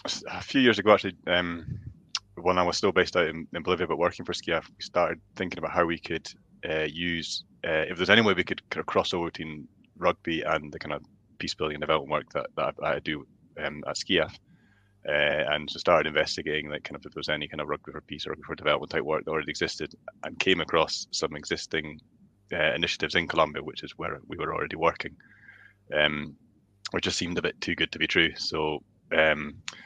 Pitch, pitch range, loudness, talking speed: 85 Hz, 75-95 Hz, -28 LUFS, 225 wpm